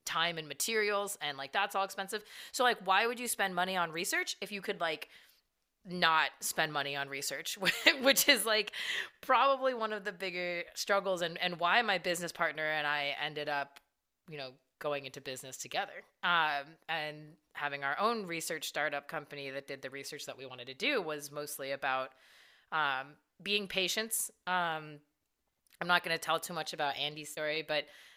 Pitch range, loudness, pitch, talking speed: 145-200 Hz, -33 LUFS, 165 Hz, 180 wpm